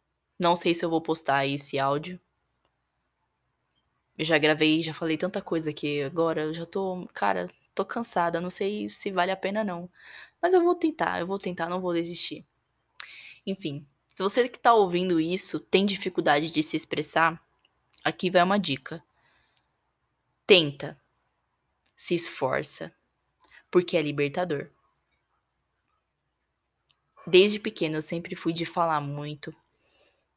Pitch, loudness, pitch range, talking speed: 165 Hz, -26 LUFS, 150-185 Hz, 140 wpm